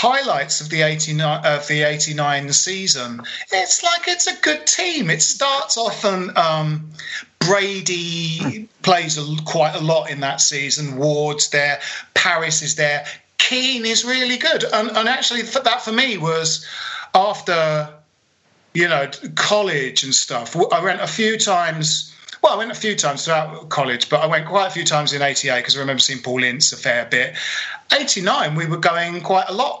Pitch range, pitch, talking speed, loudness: 150-210 Hz, 160 Hz, 180 wpm, -18 LUFS